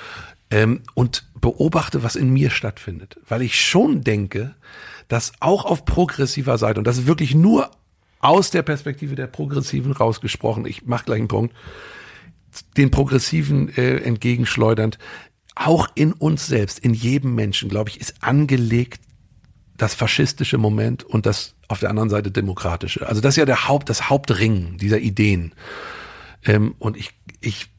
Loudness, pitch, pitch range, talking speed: -19 LUFS, 115 Hz, 105-135 Hz, 155 wpm